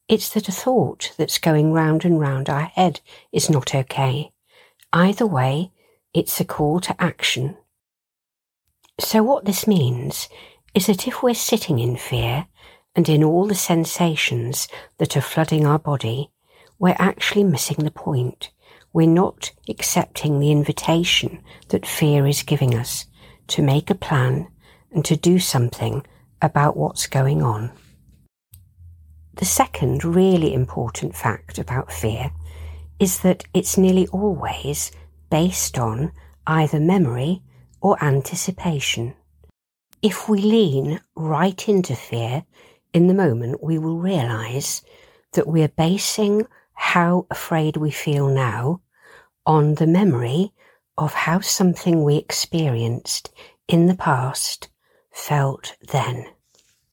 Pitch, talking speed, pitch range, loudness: 155 Hz, 130 wpm, 135-185 Hz, -20 LUFS